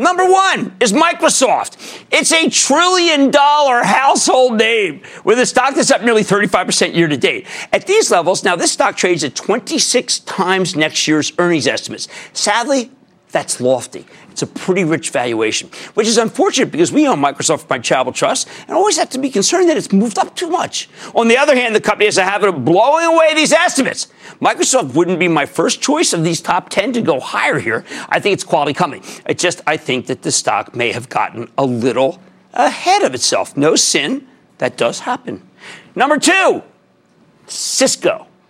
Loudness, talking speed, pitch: -14 LUFS, 185 wpm, 245 Hz